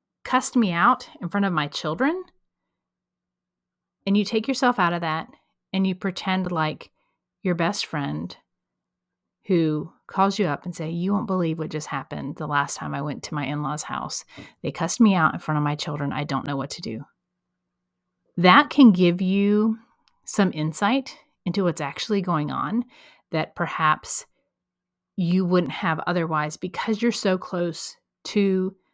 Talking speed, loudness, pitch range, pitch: 165 wpm, -24 LUFS, 150-200 Hz, 175 Hz